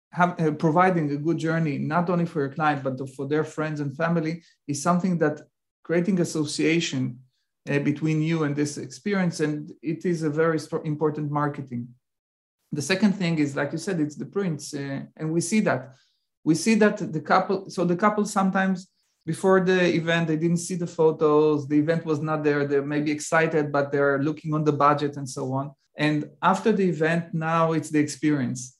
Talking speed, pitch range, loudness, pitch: 195 wpm, 145-170 Hz, -24 LUFS, 155 Hz